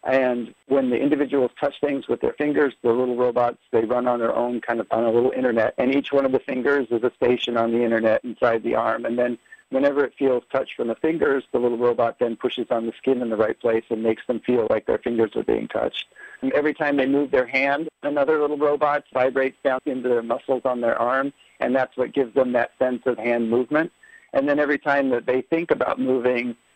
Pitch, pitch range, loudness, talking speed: 130 Hz, 120-140 Hz, -22 LUFS, 240 wpm